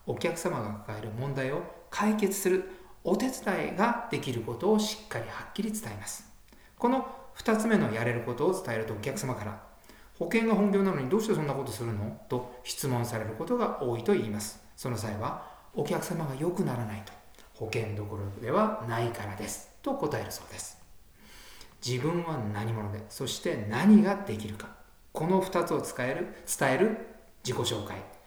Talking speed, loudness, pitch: 335 characters per minute, -31 LUFS, 125 Hz